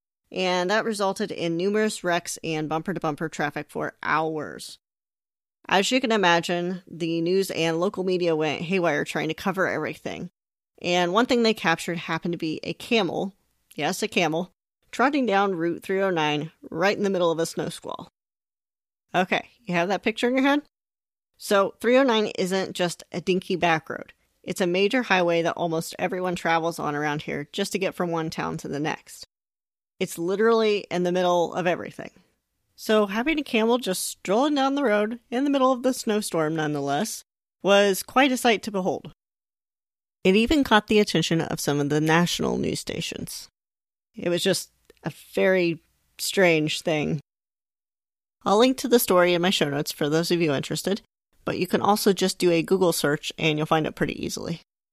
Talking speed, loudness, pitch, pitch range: 180 wpm, -24 LUFS, 185 Hz, 165-210 Hz